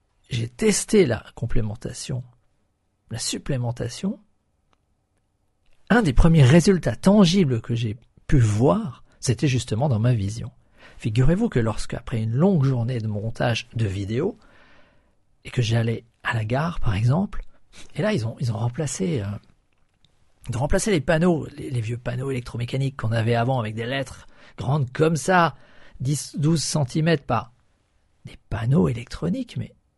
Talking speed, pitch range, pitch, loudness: 145 wpm, 115-150 Hz, 125 Hz, -23 LUFS